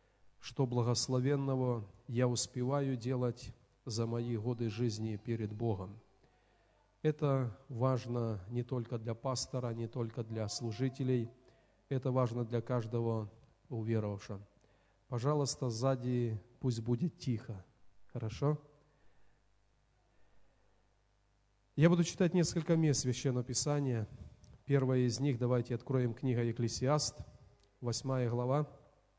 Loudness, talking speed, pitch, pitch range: -36 LUFS, 100 wpm, 120 Hz, 115-130 Hz